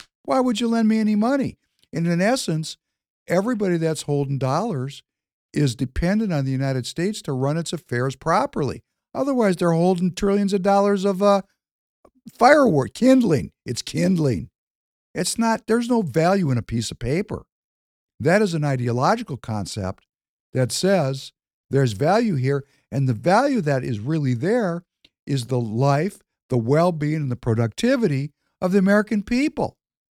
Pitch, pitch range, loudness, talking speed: 165 Hz, 135-205 Hz, -21 LUFS, 150 wpm